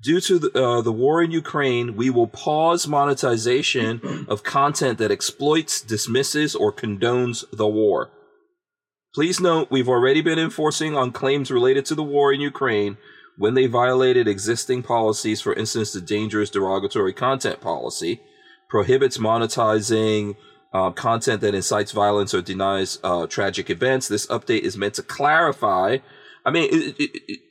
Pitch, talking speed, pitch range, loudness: 130 Hz, 155 wpm, 110-160 Hz, -21 LUFS